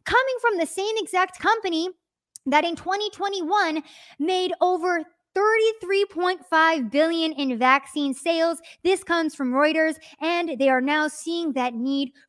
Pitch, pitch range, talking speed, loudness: 335 Hz, 300-370 Hz, 130 wpm, -23 LUFS